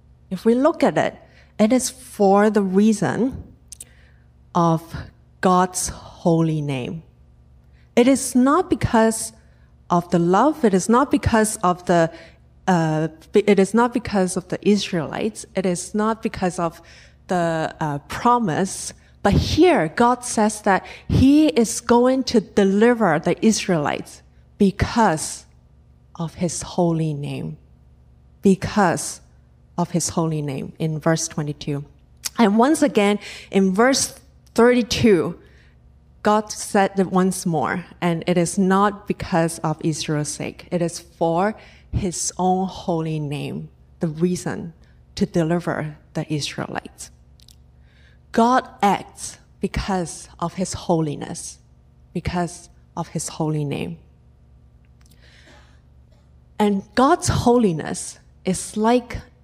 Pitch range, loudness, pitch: 125-205 Hz, -20 LUFS, 175 Hz